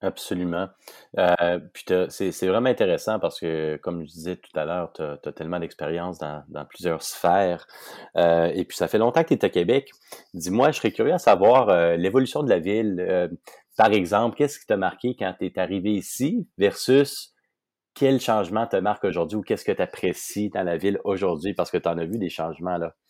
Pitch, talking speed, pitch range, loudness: 90 Hz, 215 wpm, 85-105 Hz, -23 LUFS